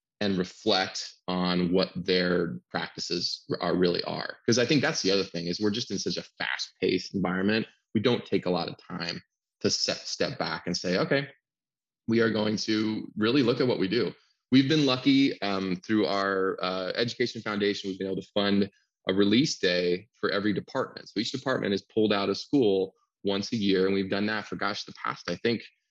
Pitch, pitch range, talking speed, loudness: 100 Hz, 90-110 Hz, 205 wpm, -28 LUFS